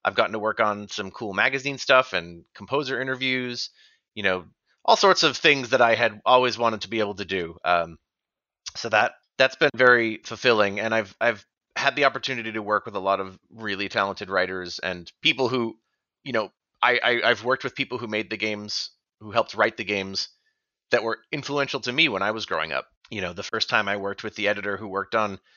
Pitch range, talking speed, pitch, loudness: 100-130 Hz, 220 wpm, 110 Hz, -24 LUFS